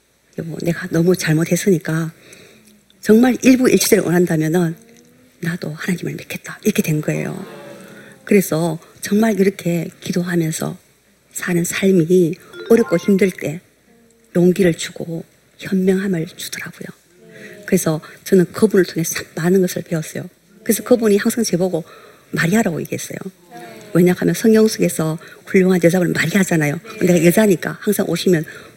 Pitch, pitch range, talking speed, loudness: 180 Hz, 170-200 Hz, 310 characters per minute, -17 LUFS